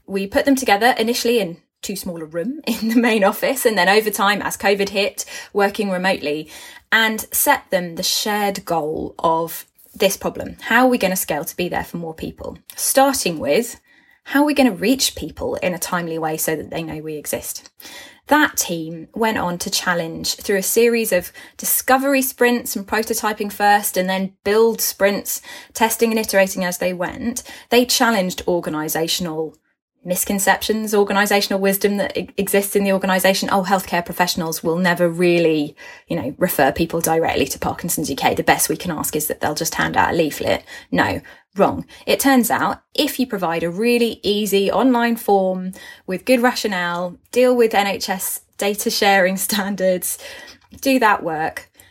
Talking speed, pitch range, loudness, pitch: 175 wpm, 180-235 Hz, -18 LUFS, 200 Hz